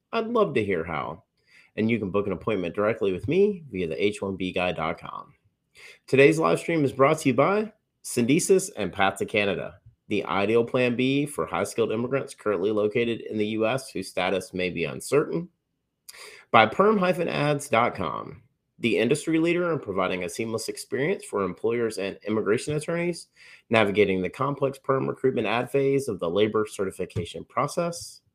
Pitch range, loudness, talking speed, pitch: 105-160 Hz, -25 LUFS, 160 wpm, 130 Hz